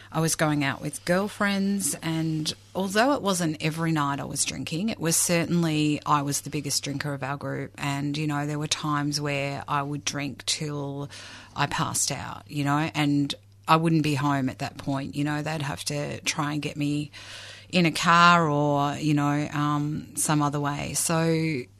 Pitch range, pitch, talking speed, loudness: 140-160 Hz, 145 Hz, 195 wpm, -25 LUFS